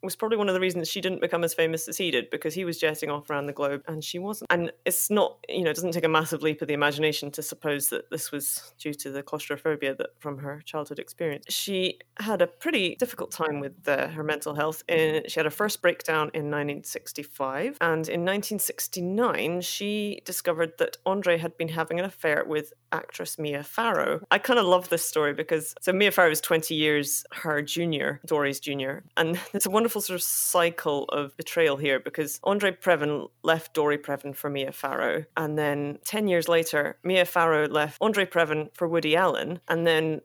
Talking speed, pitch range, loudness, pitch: 205 wpm, 150-180 Hz, -26 LUFS, 160 Hz